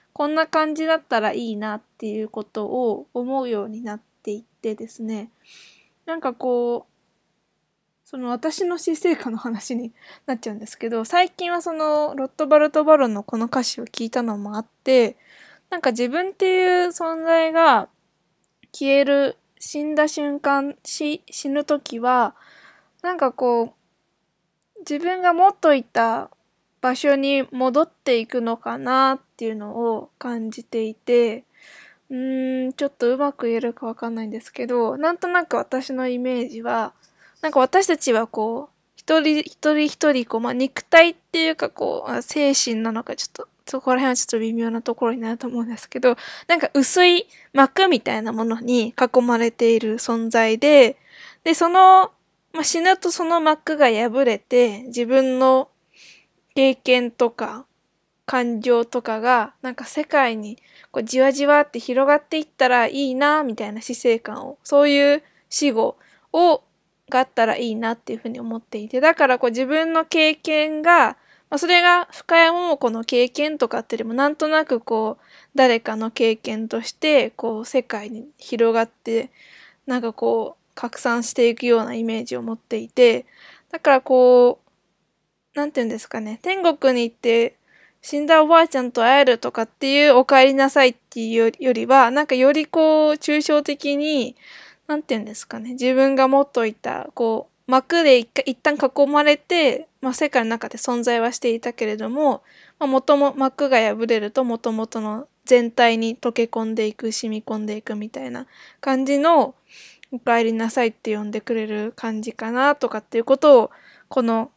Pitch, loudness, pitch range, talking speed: 255 Hz, -19 LUFS, 230-295 Hz, 320 characters per minute